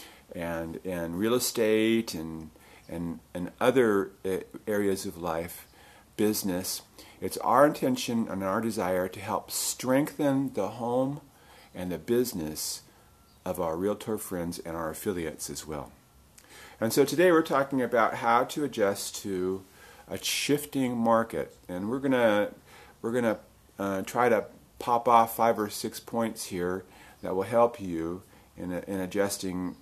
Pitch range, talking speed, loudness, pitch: 90-120 Hz, 140 wpm, -29 LUFS, 105 Hz